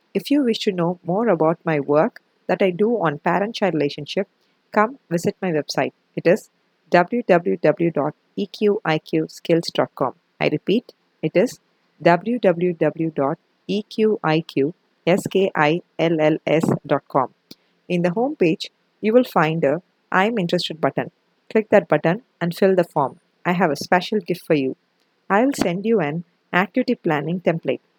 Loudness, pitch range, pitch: -21 LUFS, 160-205 Hz, 180 Hz